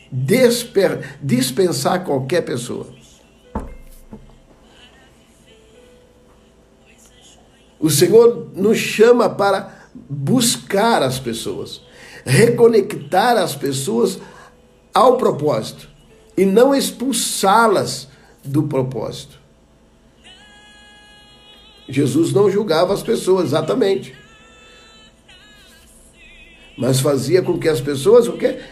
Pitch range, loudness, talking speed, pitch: 155-230 Hz, -16 LUFS, 75 wpm, 195 Hz